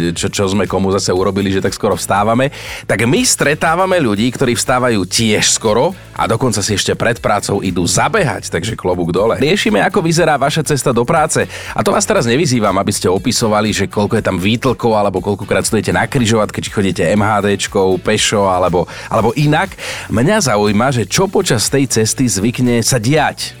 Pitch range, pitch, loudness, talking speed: 100-130 Hz, 110 Hz, -14 LUFS, 180 wpm